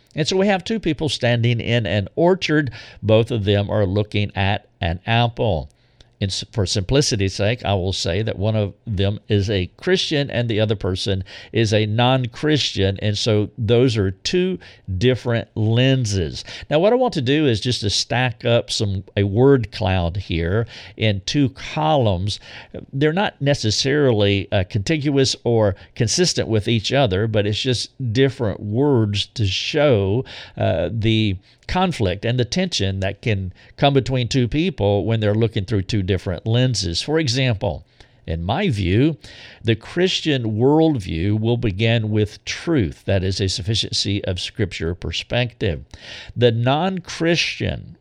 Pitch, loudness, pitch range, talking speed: 110 Hz, -20 LUFS, 100-130 Hz, 150 wpm